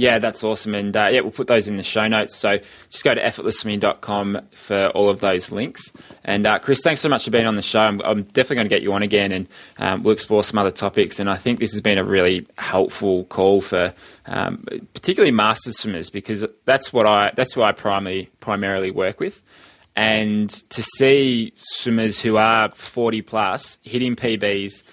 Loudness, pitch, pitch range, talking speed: -20 LUFS, 105 Hz, 100-115 Hz, 205 wpm